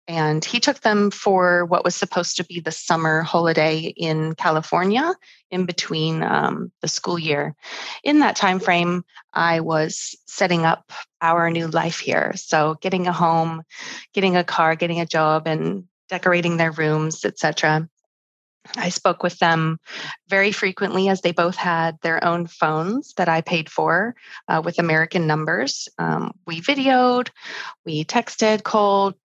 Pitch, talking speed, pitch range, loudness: 175 Hz, 155 wpm, 160-195 Hz, -20 LUFS